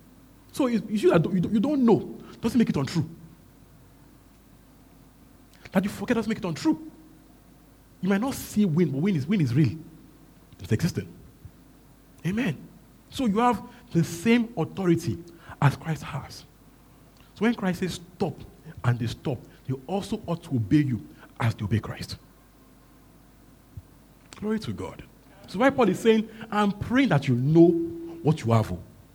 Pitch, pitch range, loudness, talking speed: 170 Hz, 140-215 Hz, -26 LUFS, 150 wpm